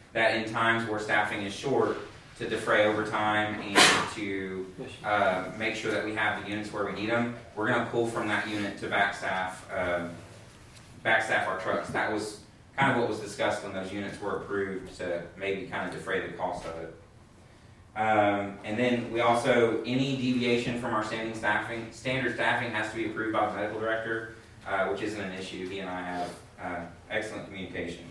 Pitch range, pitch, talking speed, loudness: 95-115 Hz, 105 Hz, 195 wpm, -29 LUFS